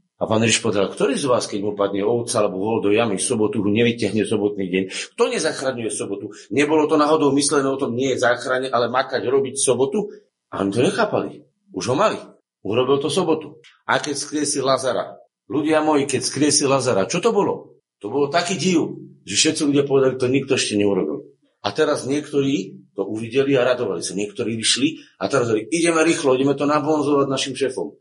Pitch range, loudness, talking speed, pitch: 110-150 Hz, -20 LUFS, 195 wpm, 135 Hz